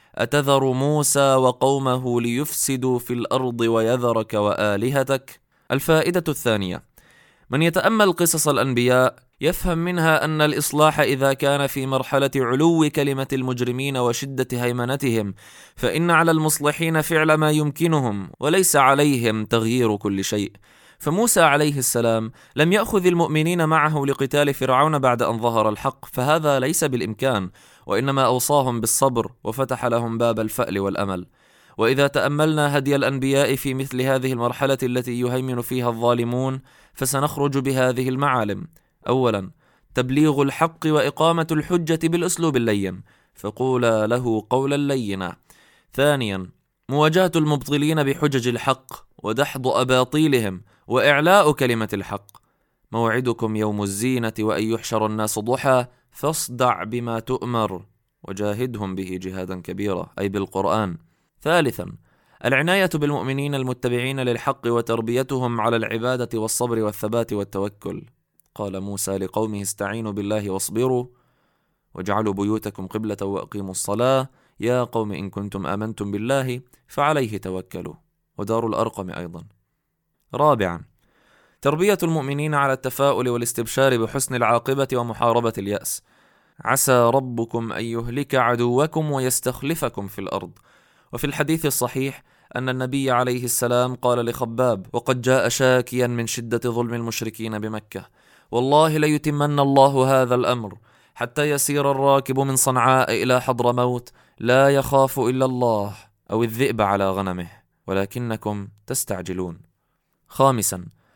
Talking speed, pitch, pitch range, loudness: 110 wpm, 125 Hz, 110-140 Hz, -21 LUFS